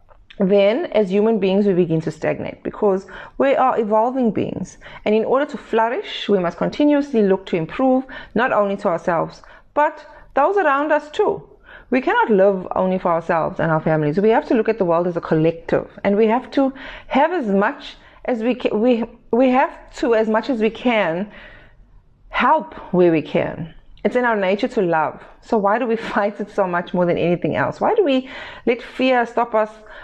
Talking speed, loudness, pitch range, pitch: 200 wpm, -19 LUFS, 195-260 Hz, 220 Hz